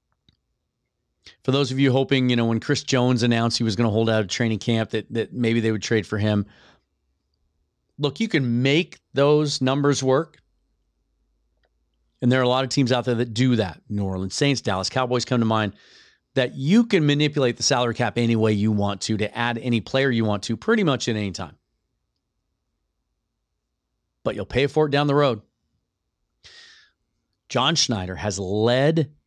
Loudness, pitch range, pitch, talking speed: -22 LUFS, 105-135 Hz, 120 Hz, 185 wpm